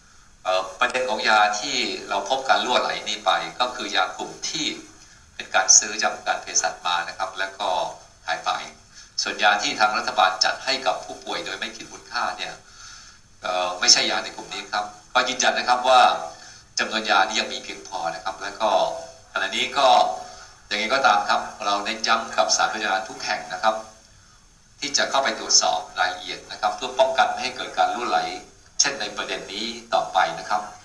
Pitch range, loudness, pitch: 95-125 Hz, -22 LUFS, 105 Hz